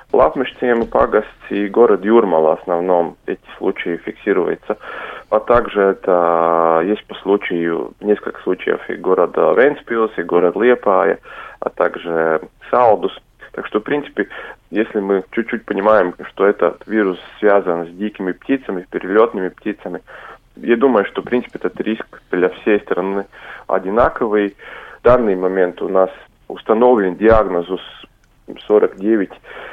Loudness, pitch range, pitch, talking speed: -17 LUFS, 85-110 Hz, 100 Hz, 130 wpm